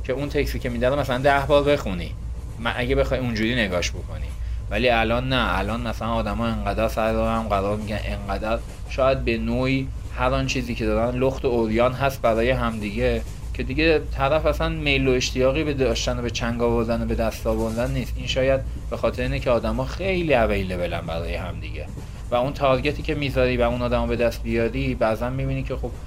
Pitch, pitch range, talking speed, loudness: 120 Hz, 110-130 Hz, 195 wpm, -23 LUFS